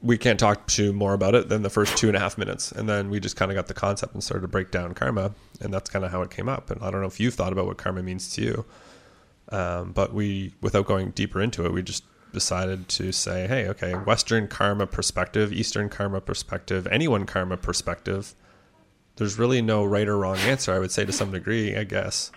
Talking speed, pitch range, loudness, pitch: 245 wpm, 95-105 Hz, -25 LUFS, 100 Hz